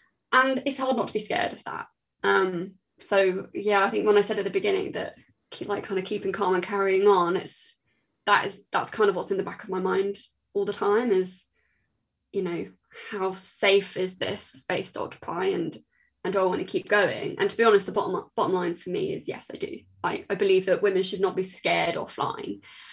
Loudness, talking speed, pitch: -26 LUFS, 235 wpm, 200 Hz